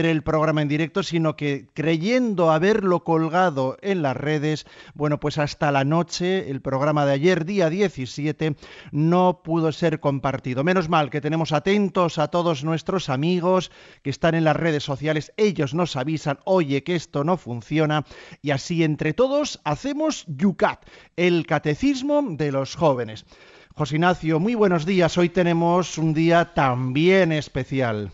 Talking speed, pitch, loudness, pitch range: 155 wpm, 160 Hz, -22 LUFS, 150-180 Hz